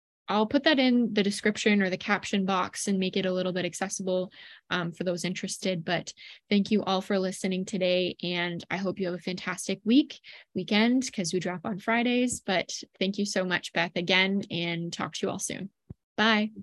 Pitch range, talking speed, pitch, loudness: 180-210 Hz, 200 wpm, 190 Hz, -28 LUFS